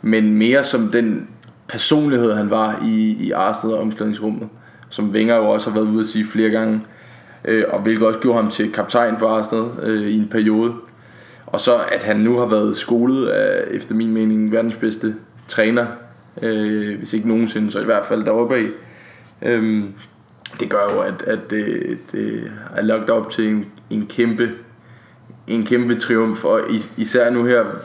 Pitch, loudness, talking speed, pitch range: 110 Hz, -18 LUFS, 175 wpm, 110-120 Hz